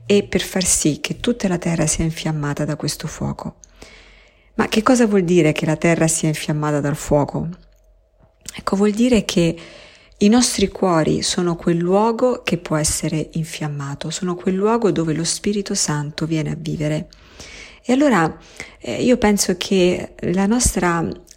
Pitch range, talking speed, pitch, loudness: 155-205 Hz, 155 wpm, 175 Hz, -19 LUFS